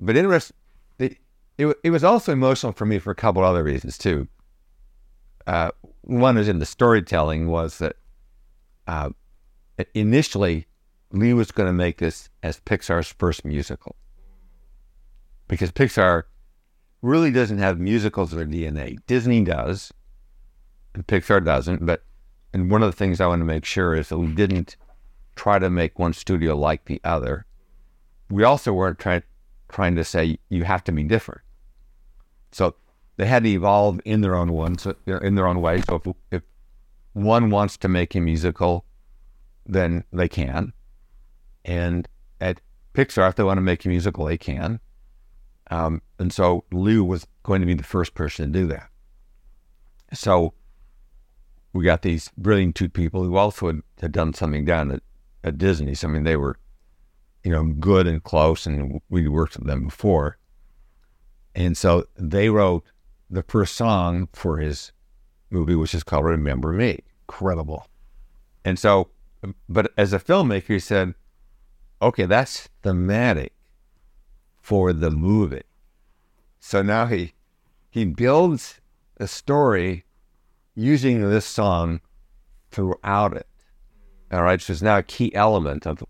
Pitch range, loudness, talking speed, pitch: 80-100 Hz, -22 LUFS, 155 wpm, 90 Hz